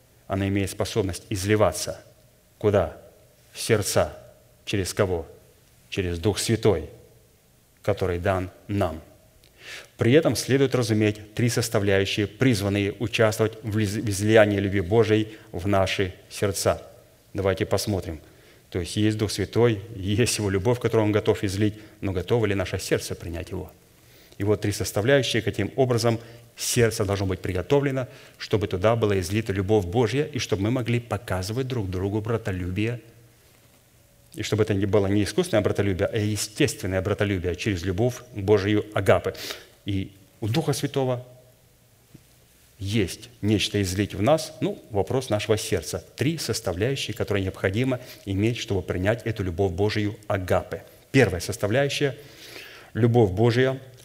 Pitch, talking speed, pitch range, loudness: 105 Hz, 130 wpm, 100-120 Hz, -25 LUFS